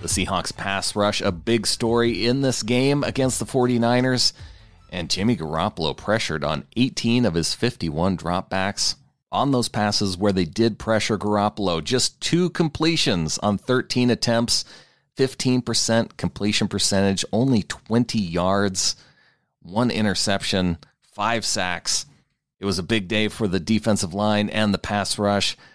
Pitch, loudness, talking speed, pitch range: 105 Hz, -22 LUFS, 140 wpm, 95-120 Hz